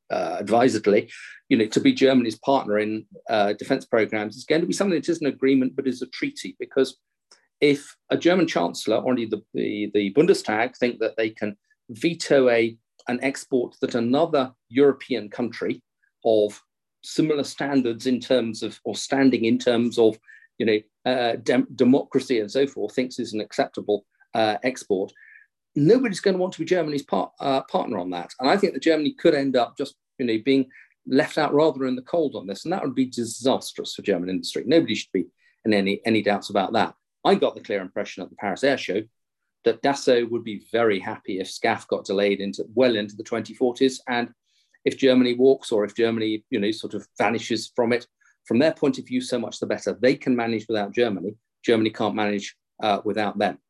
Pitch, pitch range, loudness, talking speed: 125 Hz, 110-140 Hz, -23 LUFS, 200 wpm